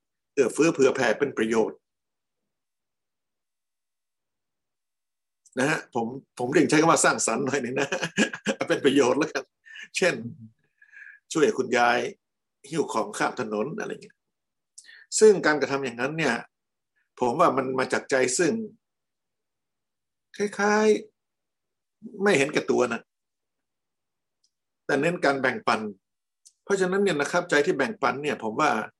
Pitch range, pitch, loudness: 140-220 Hz, 200 Hz, -24 LUFS